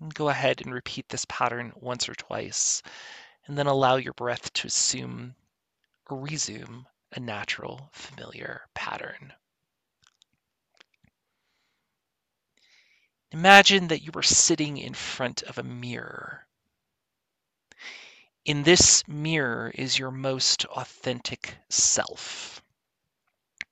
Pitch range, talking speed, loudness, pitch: 120-150 Hz, 100 wpm, -23 LUFS, 135 Hz